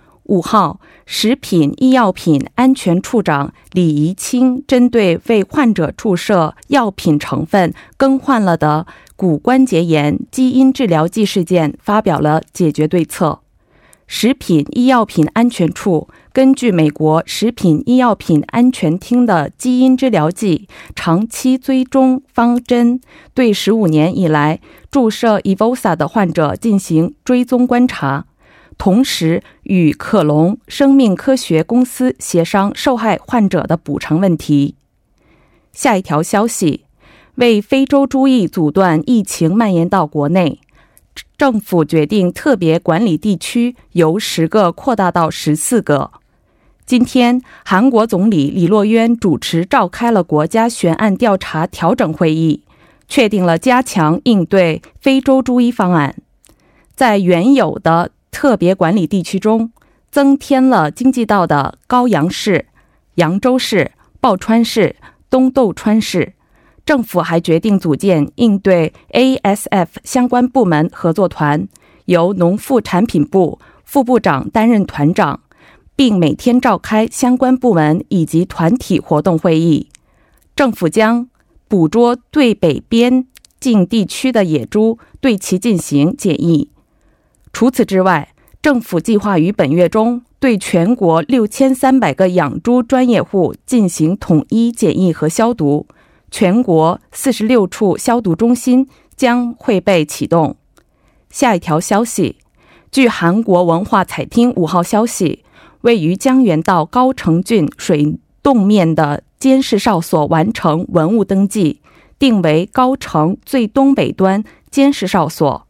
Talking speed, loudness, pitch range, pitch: 205 characters per minute, -13 LUFS, 165-245 Hz, 200 Hz